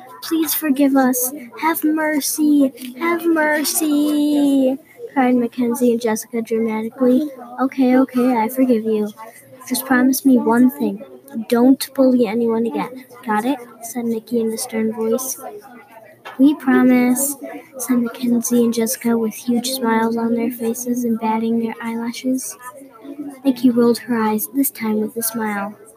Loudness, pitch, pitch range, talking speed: -18 LUFS, 250 Hz, 230-270 Hz, 135 wpm